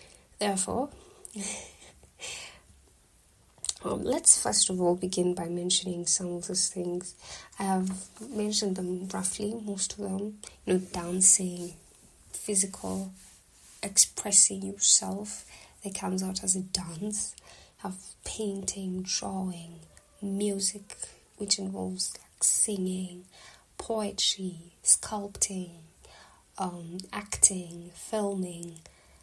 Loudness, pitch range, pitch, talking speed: -27 LUFS, 175-200 Hz, 185 Hz, 95 wpm